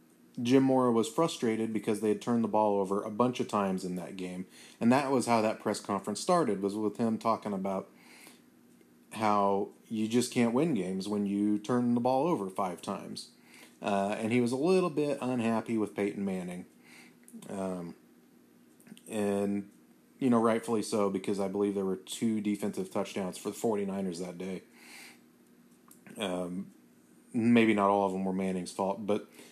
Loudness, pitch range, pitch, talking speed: -31 LUFS, 95-115 Hz, 105 Hz, 175 wpm